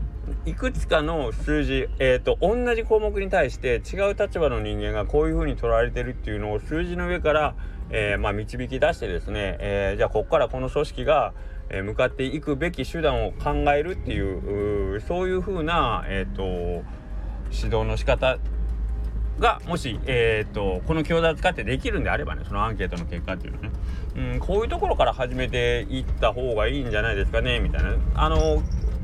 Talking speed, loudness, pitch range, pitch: 385 characters per minute, -25 LUFS, 95-150 Hz, 115 Hz